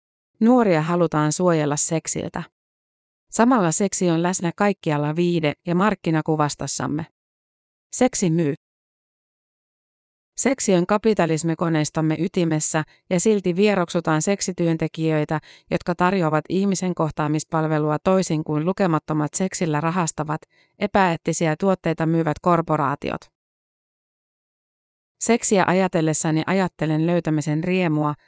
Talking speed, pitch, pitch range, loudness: 85 wpm, 170 Hz, 155-185 Hz, -21 LUFS